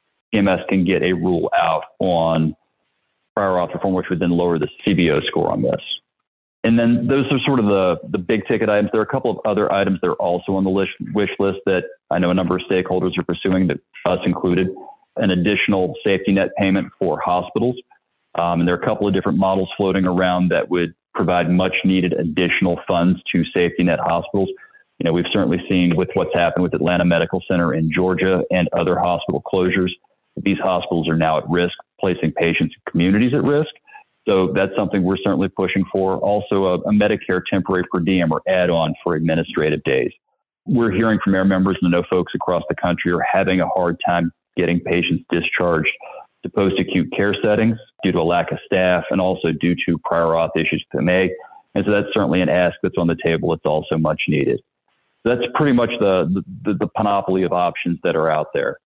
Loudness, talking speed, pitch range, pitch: -19 LUFS, 210 wpm, 85-100 Hz, 90 Hz